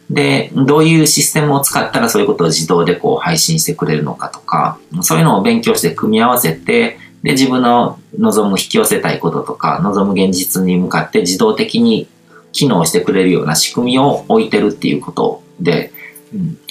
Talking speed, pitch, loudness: 390 characters per minute, 155 Hz, -13 LUFS